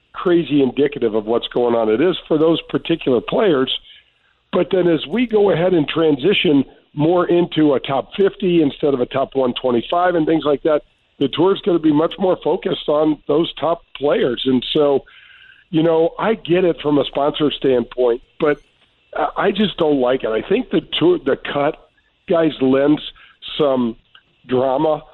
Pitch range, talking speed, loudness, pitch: 135-175 Hz, 180 wpm, -17 LUFS, 155 Hz